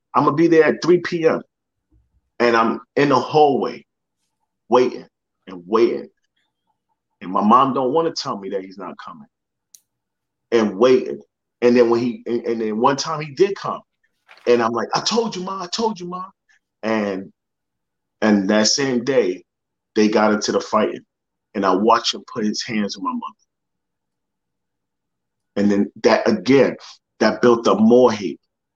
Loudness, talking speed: -18 LUFS, 170 wpm